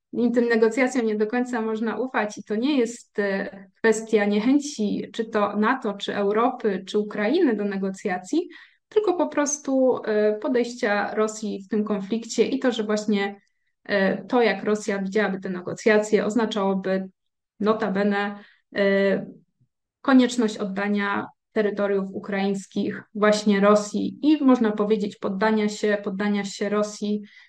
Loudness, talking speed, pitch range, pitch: -23 LUFS, 120 wpm, 205-230 Hz, 210 Hz